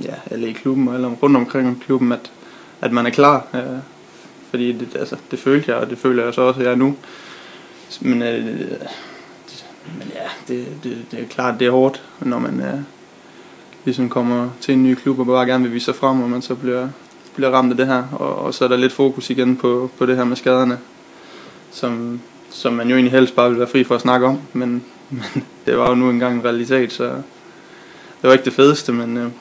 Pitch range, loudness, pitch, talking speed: 120-130 Hz, -18 LUFS, 125 Hz, 235 wpm